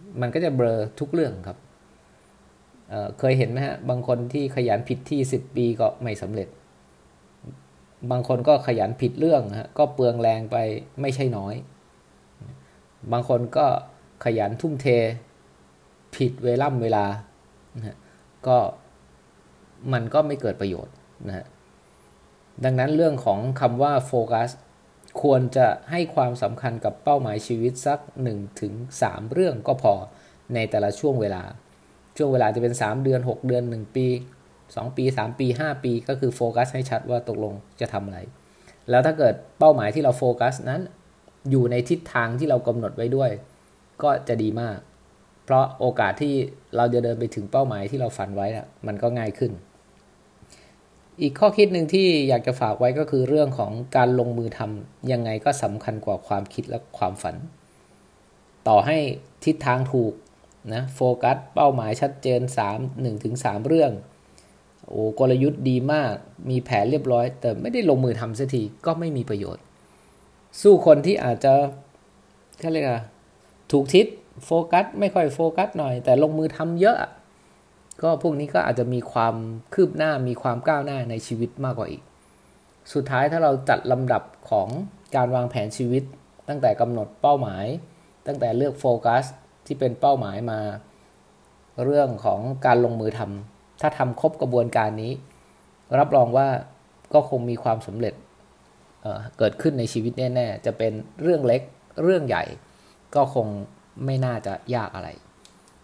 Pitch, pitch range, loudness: 120 Hz, 105-135 Hz, -23 LUFS